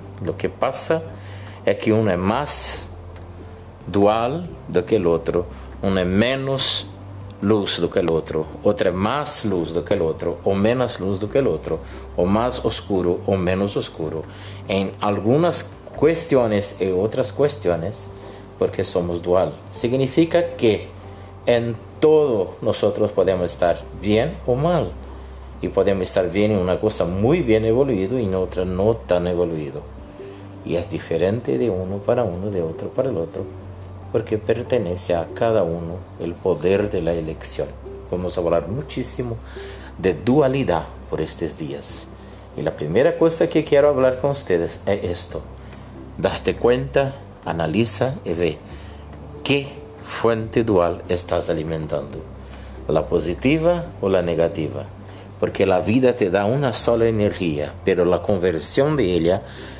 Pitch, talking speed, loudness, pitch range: 100 Hz, 145 wpm, -20 LUFS, 85-115 Hz